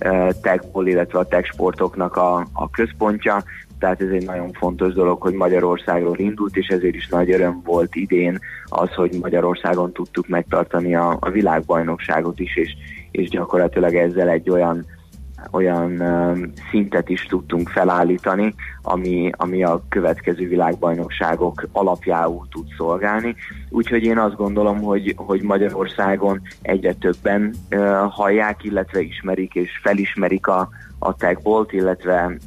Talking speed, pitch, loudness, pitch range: 130 wpm, 90 Hz, -19 LUFS, 85-95 Hz